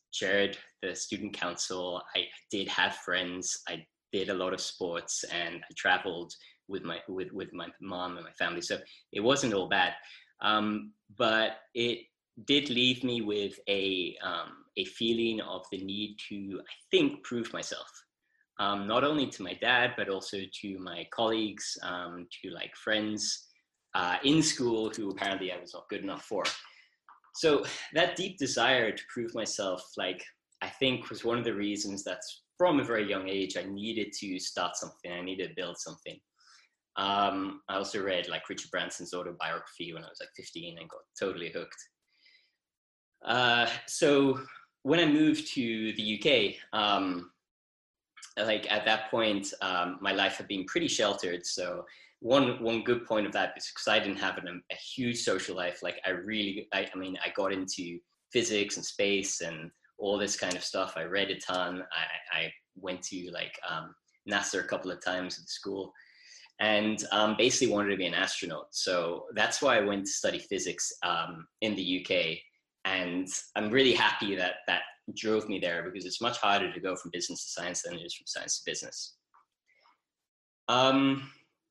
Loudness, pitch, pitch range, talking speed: -31 LUFS, 105 Hz, 95-115 Hz, 180 wpm